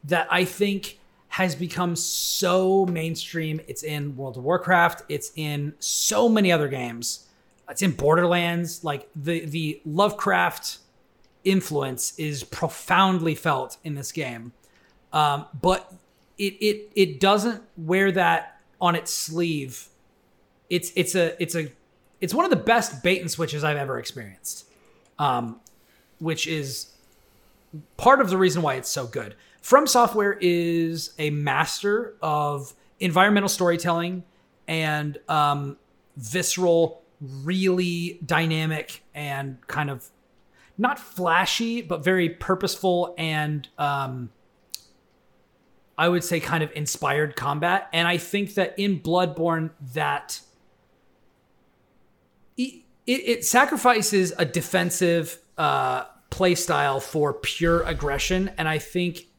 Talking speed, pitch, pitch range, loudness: 120 wpm, 170 Hz, 150-185 Hz, -24 LUFS